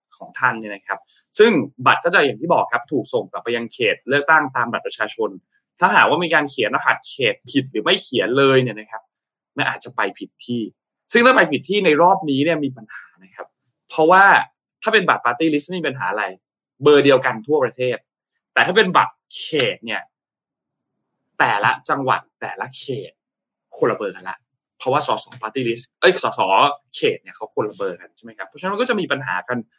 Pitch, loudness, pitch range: 135 Hz, -18 LUFS, 115-180 Hz